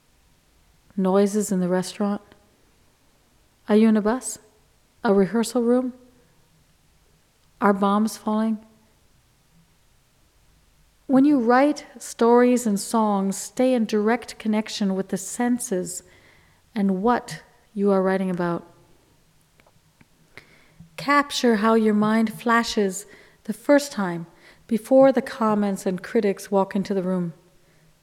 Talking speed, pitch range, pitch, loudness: 110 wpm, 190-235 Hz, 210 Hz, -22 LUFS